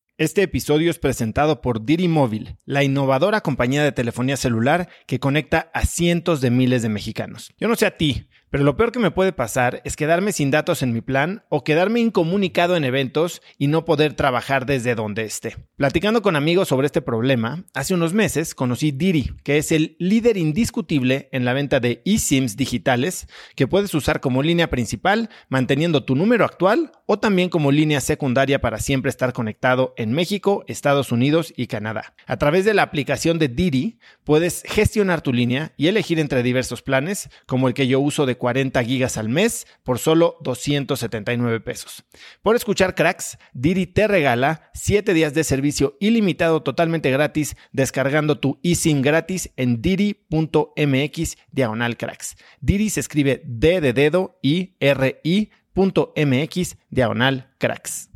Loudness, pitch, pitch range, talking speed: -20 LUFS, 145 Hz, 130-170 Hz, 165 wpm